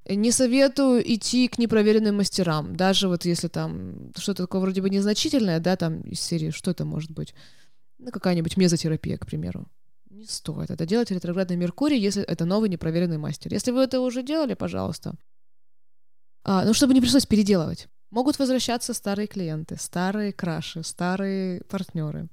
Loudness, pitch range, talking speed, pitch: -24 LUFS, 170-230 Hz, 160 wpm, 190 Hz